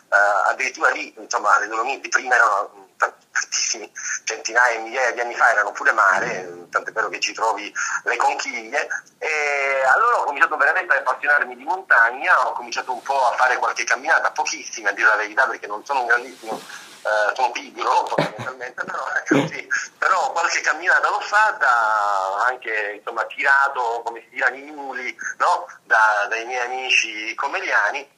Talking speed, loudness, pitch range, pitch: 165 wpm, -20 LUFS, 115-140 Hz, 120 Hz